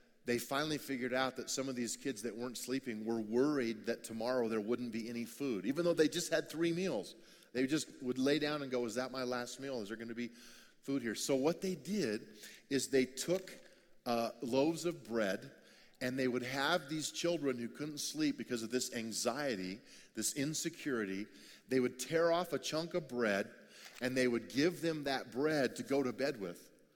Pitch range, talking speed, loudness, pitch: 120-150 Hz, 205 wpm, -37 LUFS, 130 Hz